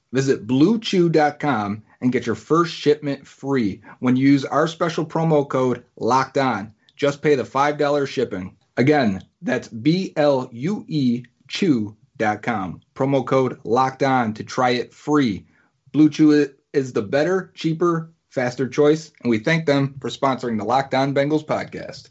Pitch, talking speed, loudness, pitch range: 135 Hz, 140 wpm, -21 LUFS, 125-150 Hz